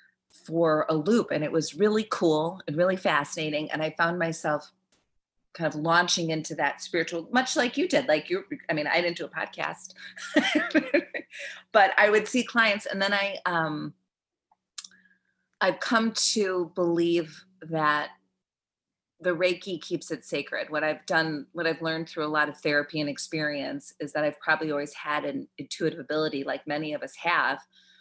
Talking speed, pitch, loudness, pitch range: 170 wpm, 165 Hz, -27 LUFS, 155-200 Hz